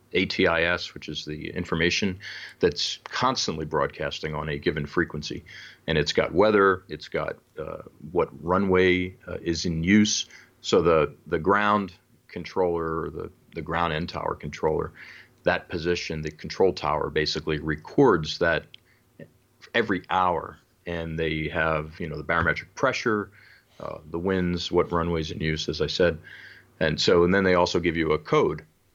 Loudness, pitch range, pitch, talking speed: -25 LUFS, 80-95 Hz, 85 Hz, 155 wpm